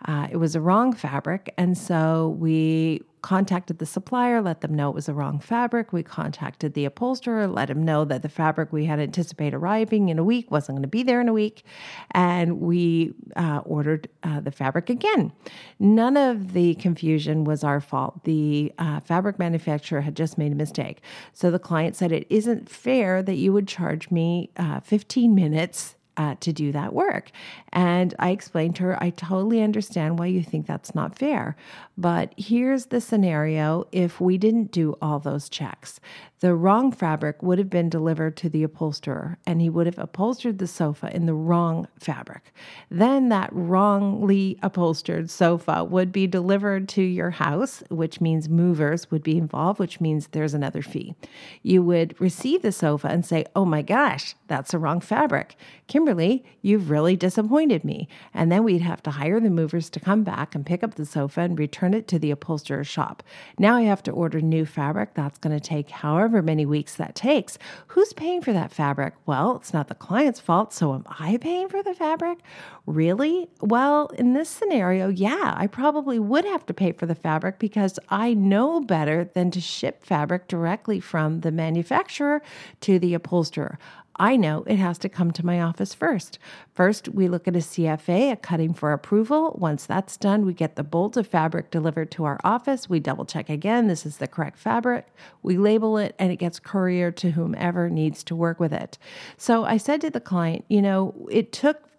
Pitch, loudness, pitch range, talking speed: 175 Hz, -23 LUFS, 160-210 Hz, 195 wpm